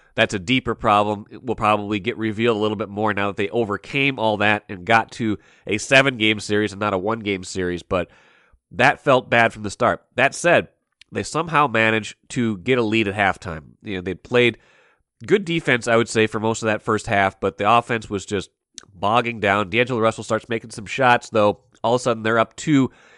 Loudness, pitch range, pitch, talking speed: -20 LUFS, 105-120 Hz, 110 Hz, 225 wpm